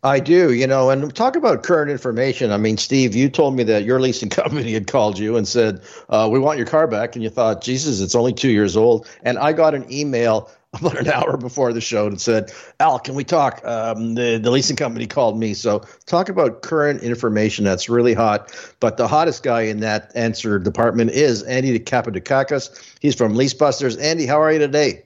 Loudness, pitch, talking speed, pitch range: -18 LUFS, 120 Hz, 215 wpm, 110-135 Hz